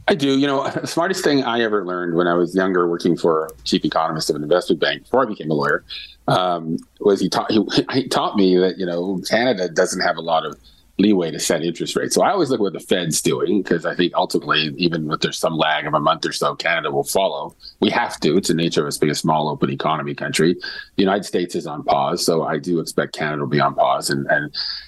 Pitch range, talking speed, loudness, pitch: 80-95 Hz, 255 wpm, -19 LUFS, 85 Hz